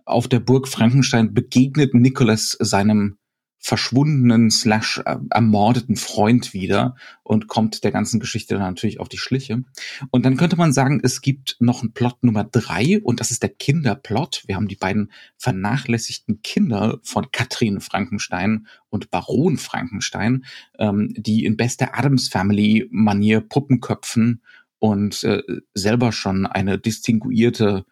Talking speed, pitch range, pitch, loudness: 135 wpm, 105-125 Hz, 115 Hz, -19 LUFS